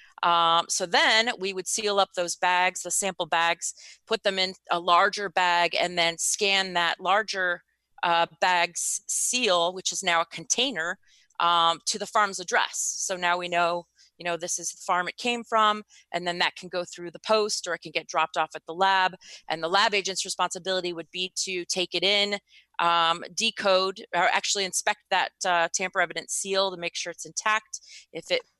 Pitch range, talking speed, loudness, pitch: 170-195 Hz, 195 wpm, -25 LUFS, 180 Hz